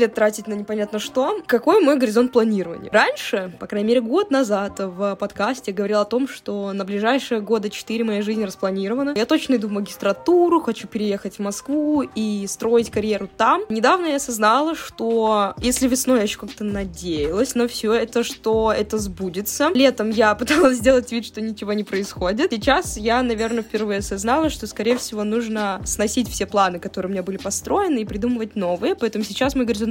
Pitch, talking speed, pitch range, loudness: 220 Hz, 180 wpm, 205-250 Hz, -21 LUFS